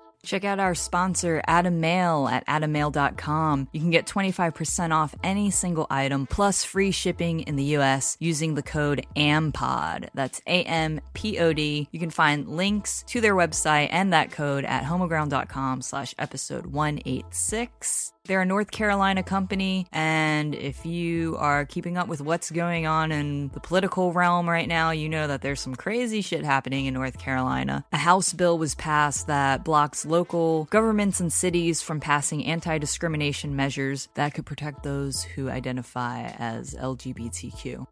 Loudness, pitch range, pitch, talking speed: -25 LUFS, 140-175 Hz, 155 Hz, 155 wpm